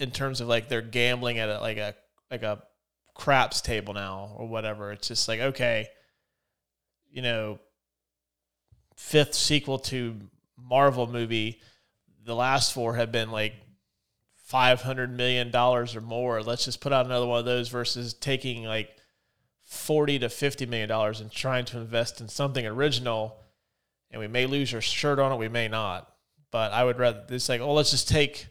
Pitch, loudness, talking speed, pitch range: 120 Hz, -27 LUFS, 175 wpm, 110-125 Hz